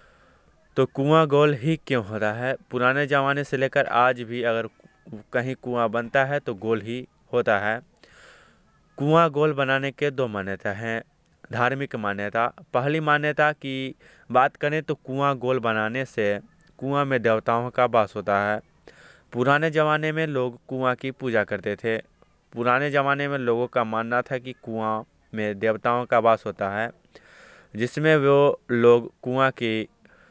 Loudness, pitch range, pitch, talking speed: -24 LUFS, 115-140 Hz, 125 Hz, 155 wpm